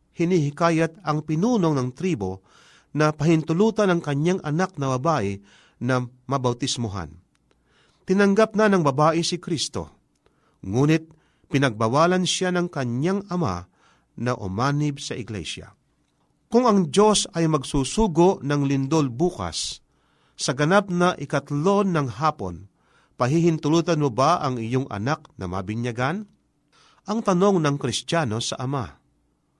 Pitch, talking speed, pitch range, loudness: 150 Hz, 120 wpm, 130-175 Hz, -23 LUFS